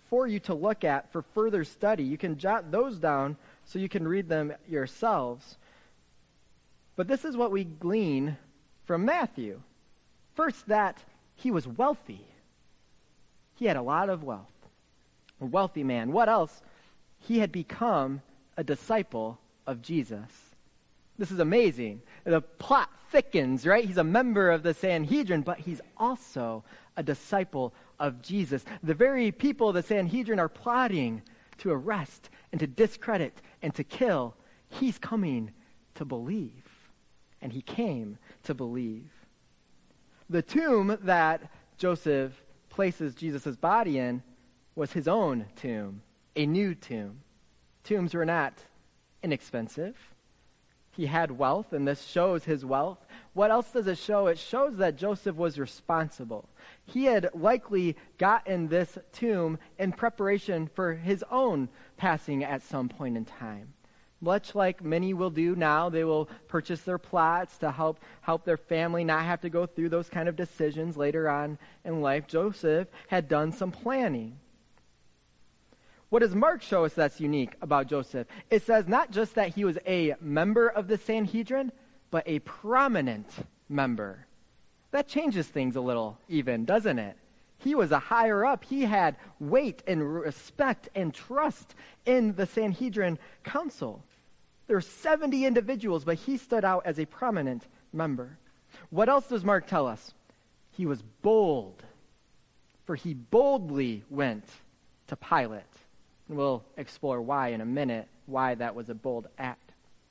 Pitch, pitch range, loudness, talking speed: 165 Hz, 135-210 Hz, -29 LUFS, 150 wpm